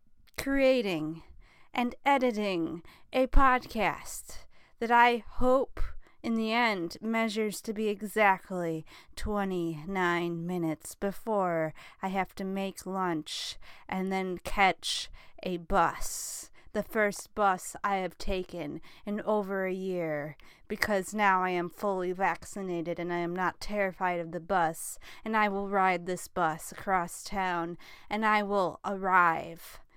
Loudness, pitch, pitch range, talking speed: -30 LUFS, 190 Hz, 175-210 Hz, 130 wpm